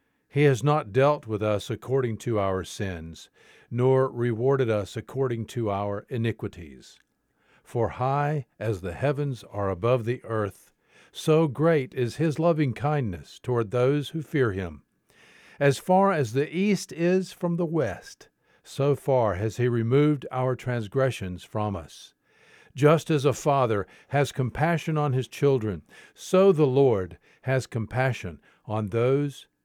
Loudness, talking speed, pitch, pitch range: -26 LUFS, 145 wpm, 130 Hz, 110-145 Hz